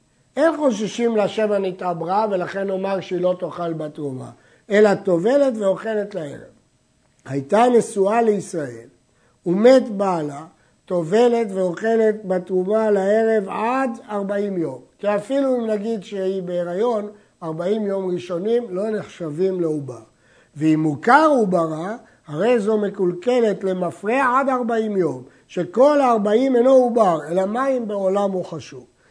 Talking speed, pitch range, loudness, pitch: 115 wpm, 175-225 Hz, -20 LUFS, 195 Hz